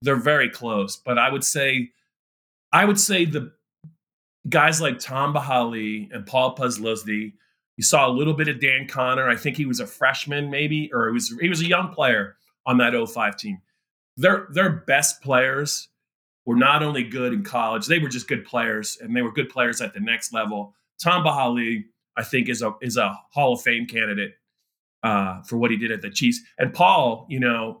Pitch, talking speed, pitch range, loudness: 130 Hz, 200 wpm, 115-155 Hz, -21 LUFS